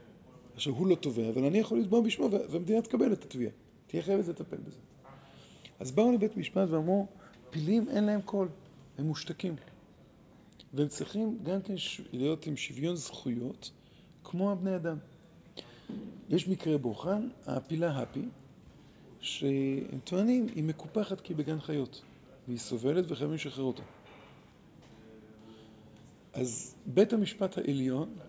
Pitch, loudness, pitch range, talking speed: 165 Hz, -33 LUFS, 135-195 Hz, 130 wpm